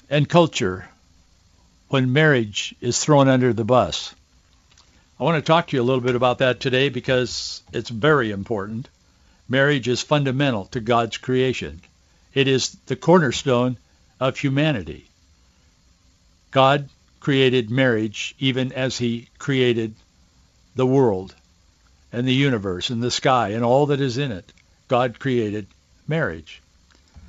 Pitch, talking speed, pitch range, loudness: 120 Hz, 135 wpm, 85-130 Hz, -20 LUFS